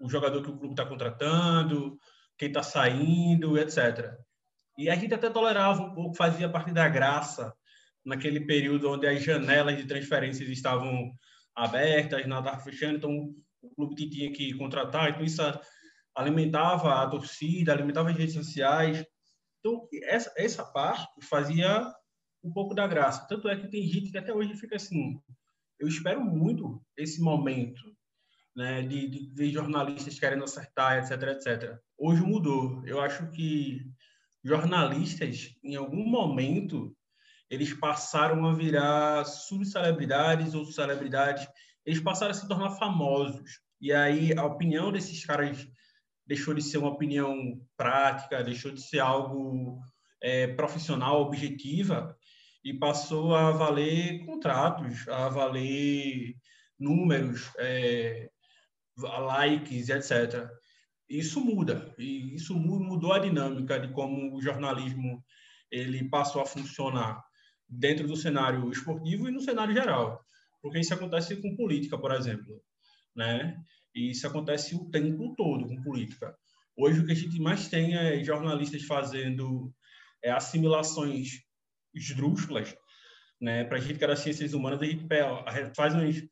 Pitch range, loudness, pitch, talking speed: 135-165 Hz, -29 LUFS, 145 Hz, 135 wpm